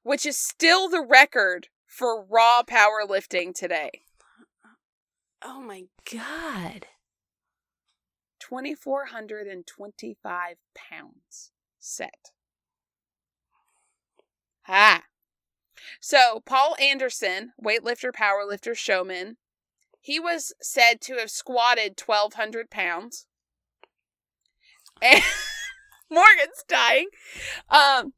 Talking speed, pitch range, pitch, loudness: 85 wpm, 210-285 Hz, 240 Hz, -20 LUFS